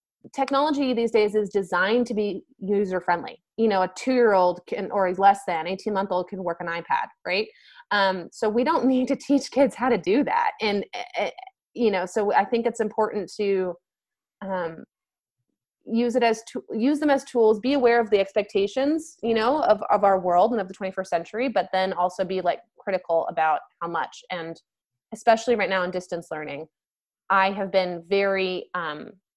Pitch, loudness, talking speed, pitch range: 205 Hz, -24 LUFS, 185 wpm, 185-235 Hz